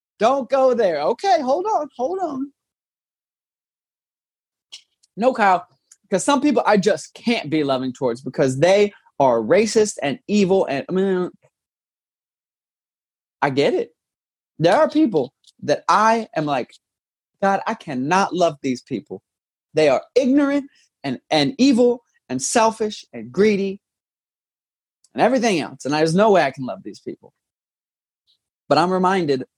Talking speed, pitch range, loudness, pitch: 140 wpm, 180-265 Hz, -19 LUFS, 210 Hz